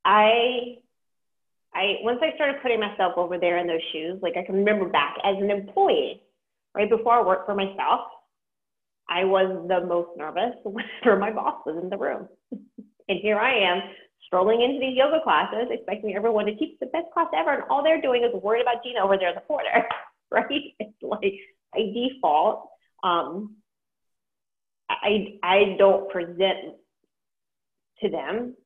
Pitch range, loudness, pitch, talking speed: 185-245 Hz, -24 LUFS, 210 Hz, 165 wpm